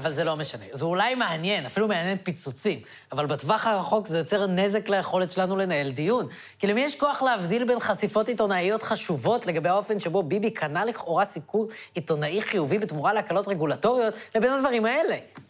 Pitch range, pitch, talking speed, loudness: 170-220 Hz, 200 Hz, 170 wpm, -26 LUFS